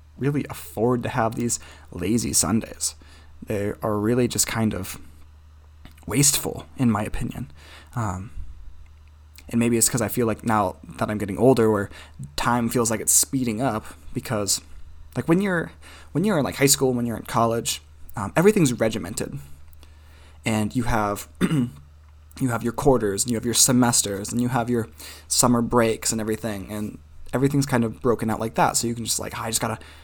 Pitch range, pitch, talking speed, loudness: 75-120 Hz, 110 Hz, 180 wpm, -23 LUFS